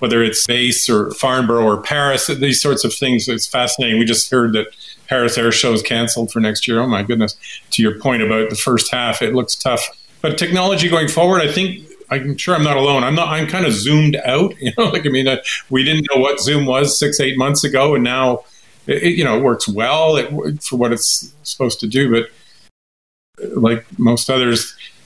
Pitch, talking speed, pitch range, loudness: 130 Hz, 220 wpm, 115-145 Hz, -15 LUFS